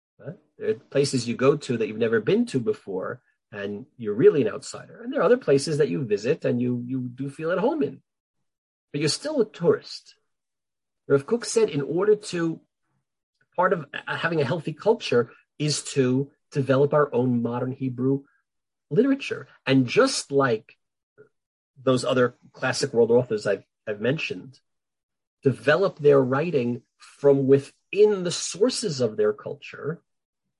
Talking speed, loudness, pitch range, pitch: 155 wpm, -24 LUFS, 130-215 Hz, 145 Hz